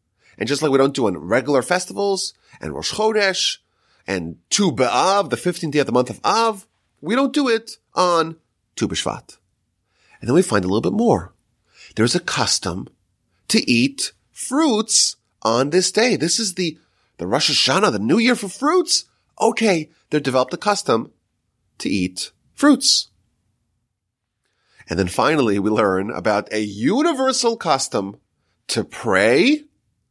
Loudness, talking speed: -19 LUFS, 155 wpm